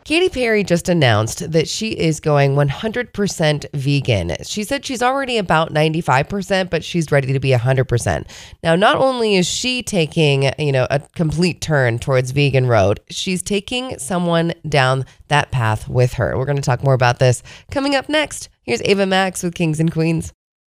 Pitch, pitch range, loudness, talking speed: 160 Hz, 135-195 Hz, -17 LUFS, 175 wpm